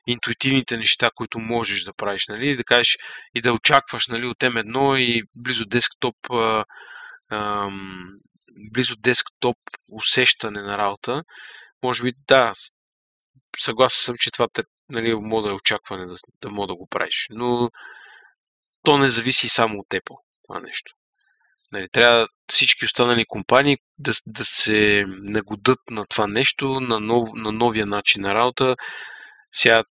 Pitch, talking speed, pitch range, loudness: 115 Hz, 145 wpm, 105-125 Hz, -19 LUFS